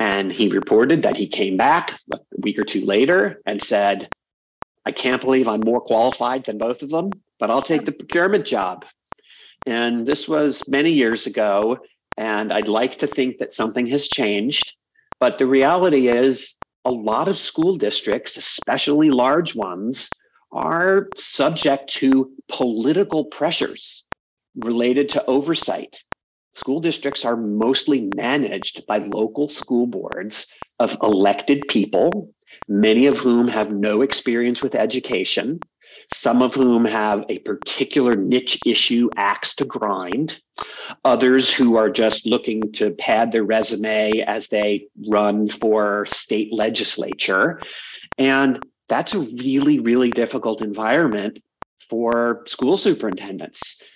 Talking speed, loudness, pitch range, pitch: 135 wpm, -19 LUFS, 110-140 Hz, 125 Hz